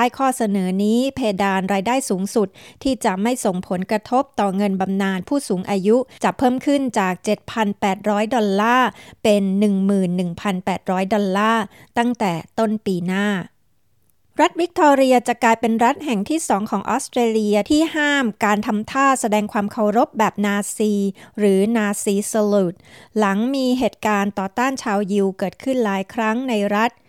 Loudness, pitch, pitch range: -19 LUFS, 215 Hz, 200-240 Hz